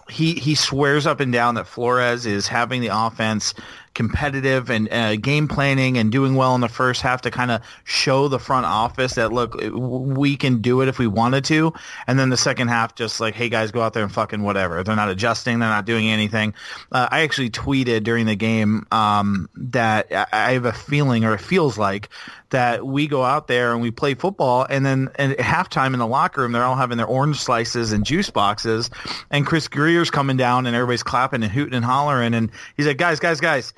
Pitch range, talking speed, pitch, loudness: 115-135 Hz, 220 wpm, 125 Hz, -20 LUFS